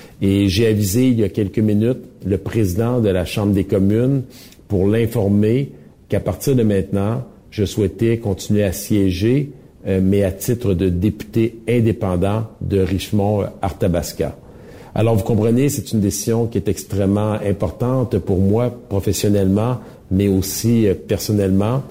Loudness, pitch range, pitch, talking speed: -18 LUFS, 100-115 Hz, 105 Hz, 140 wpm